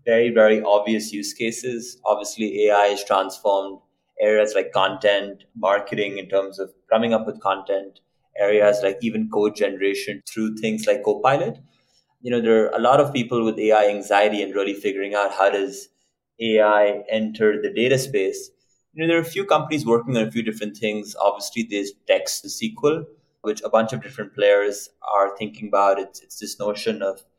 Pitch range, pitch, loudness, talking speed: 100-120 Hz, 105 Hz, -21 LUFS, 180 wpm